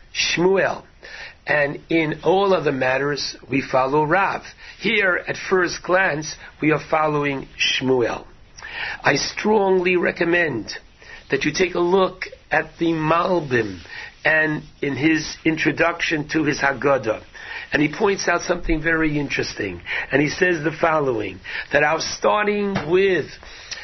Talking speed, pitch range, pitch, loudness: 130 wpm, 145-180 Hz, 160 Hz, -20 LUFS